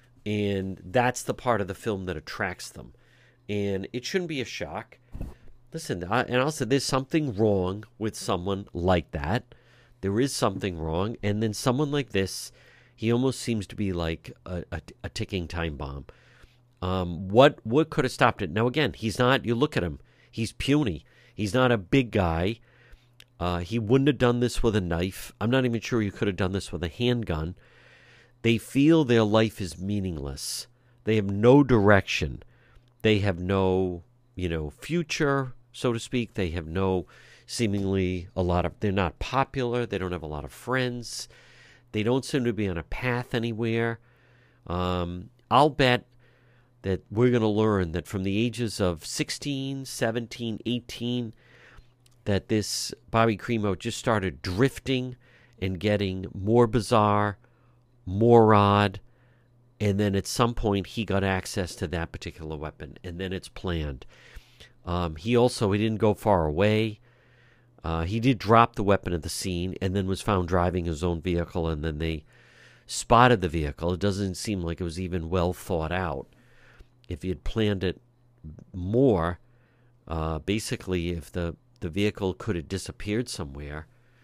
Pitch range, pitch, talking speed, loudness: 95-120 Hz, 110 Hz, 170 wpm, -26 LUFS